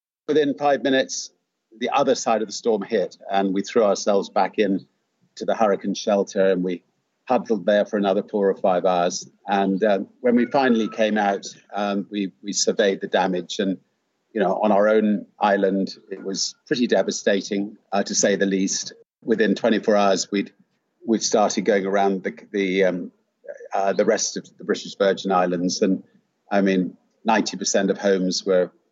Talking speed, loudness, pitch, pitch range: 180 wpm, -22 LUFS, 100 Hz, 95-105 Hz